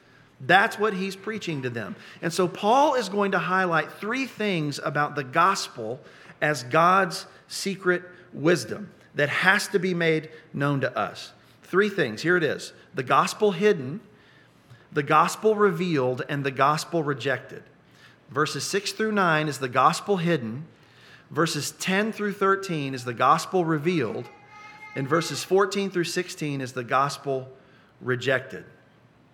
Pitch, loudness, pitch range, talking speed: 165 Hz, -24 LUFS, 140-195 Hz, 145 wpm